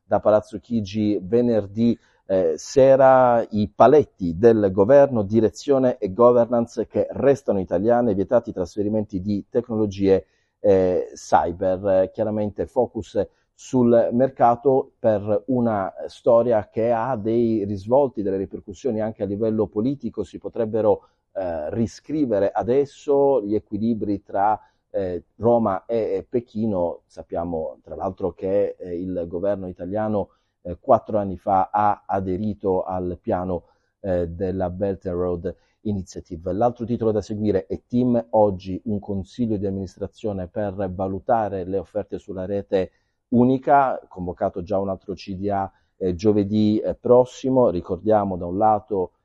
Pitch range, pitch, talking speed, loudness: 95-120 Hz, 105 Hz, 125 wpm, -22 LUFS